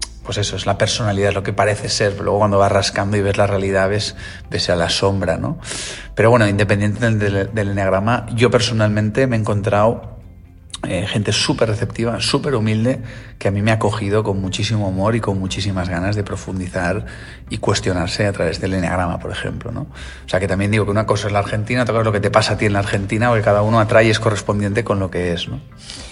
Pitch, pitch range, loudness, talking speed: 105 Hz, 95-110 Hz, -18 LUFS, 230 wpm